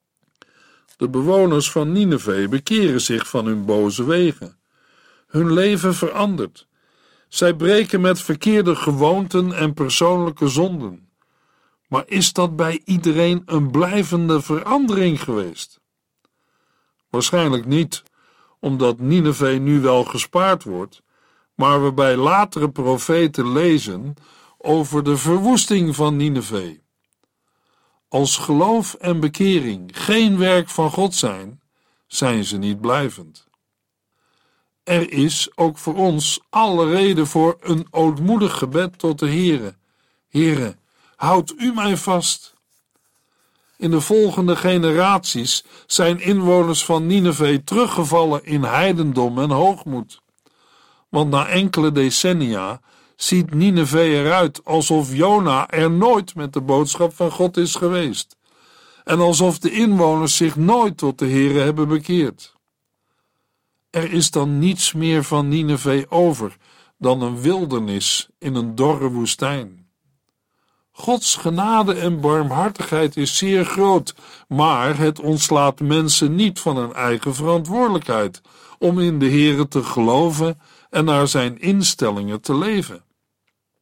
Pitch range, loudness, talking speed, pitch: 140-180 Hz, -18 LUFS, 120 wpm, 160 Hz